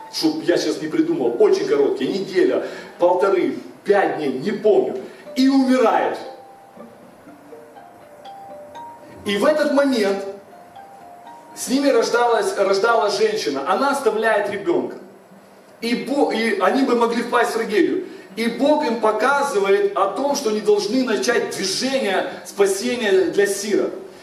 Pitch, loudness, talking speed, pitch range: 245 Hz, -19 LUFS, 125 wpm, 210-315 Hz